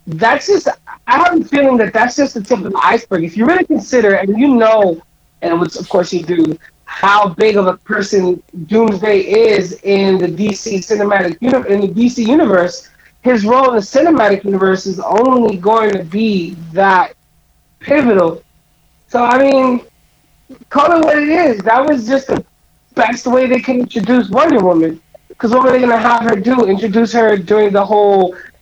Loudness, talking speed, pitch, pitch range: -12 LUFS, 180 wpm, 220 Hz, 195-255 Hz